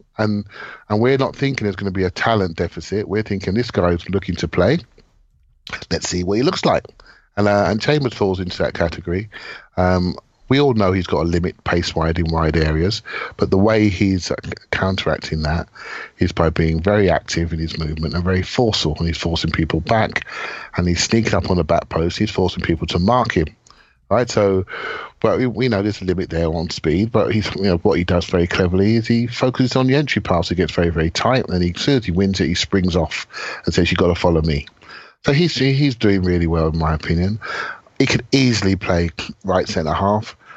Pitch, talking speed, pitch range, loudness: 90 Hz, 220 wpm, 85-105 Hz, -19 LUFS